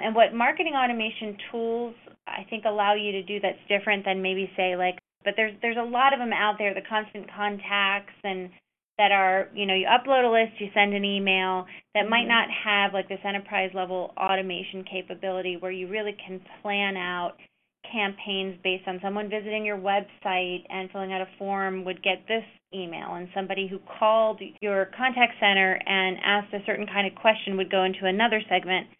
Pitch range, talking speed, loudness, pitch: 190-215 Hz, 190 wpm, -25 LUFS, 200 Hz